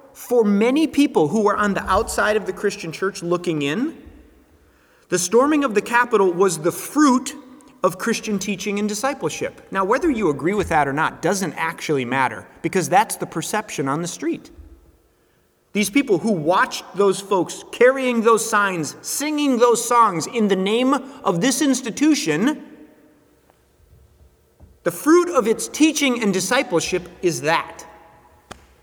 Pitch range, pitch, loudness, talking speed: 190-270 Hz, 220 Hz, -20 LUFS, 150 wpm